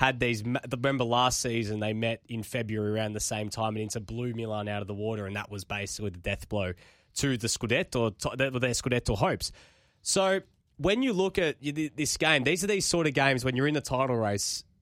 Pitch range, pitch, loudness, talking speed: 105-135 Hz, 120 Hz, -29 LUFS, 215 wpm